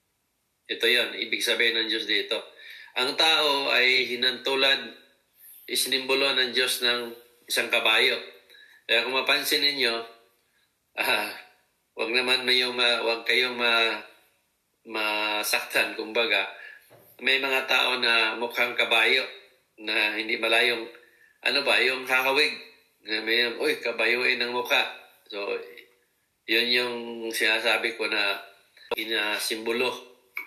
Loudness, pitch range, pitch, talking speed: -23 LUFS, 115-130 Hz, 120 Hz, 115 wpm